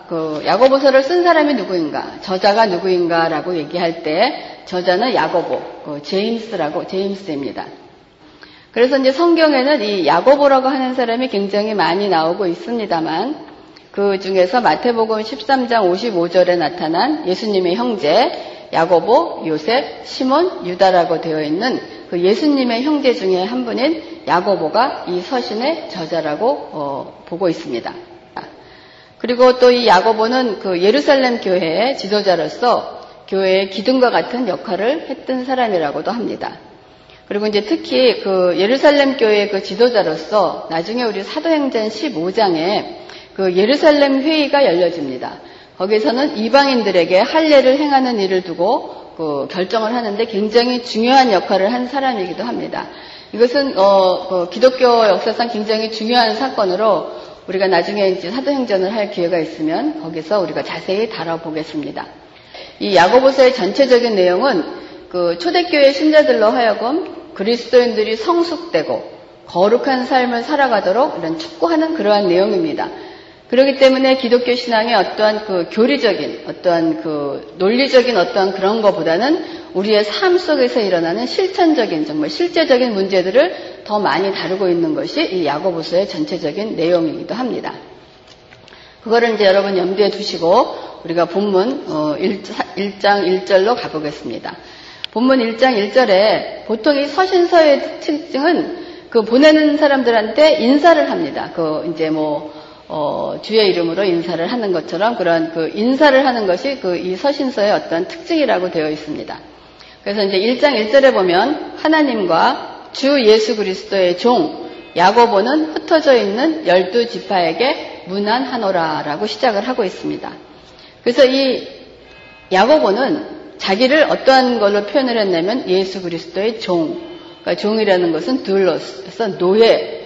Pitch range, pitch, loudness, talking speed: 185-275 Hz, 225 Hz, -15 LUFS, 320 characters per minute